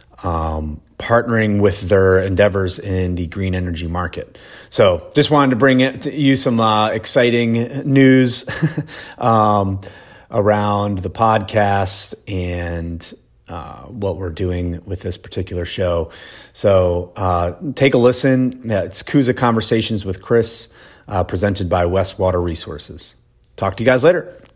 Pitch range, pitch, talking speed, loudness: 90-120 Hz, 100 Hz, 135 wpm, -17 LUFS